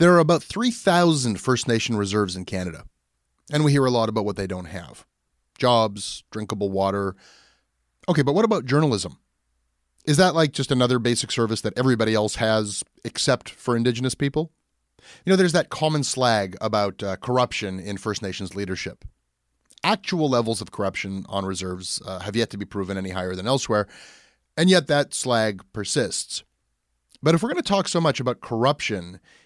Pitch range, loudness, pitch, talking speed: 95-140 Hz, -23 LUFS, 110 Hz, 175 wpm